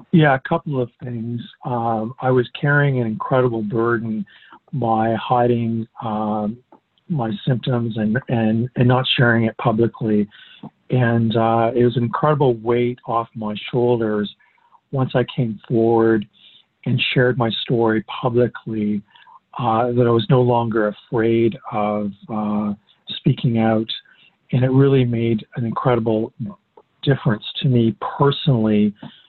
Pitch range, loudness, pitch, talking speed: 110-125 Hz, -19 LUFS, 115 Hz, 130 wpm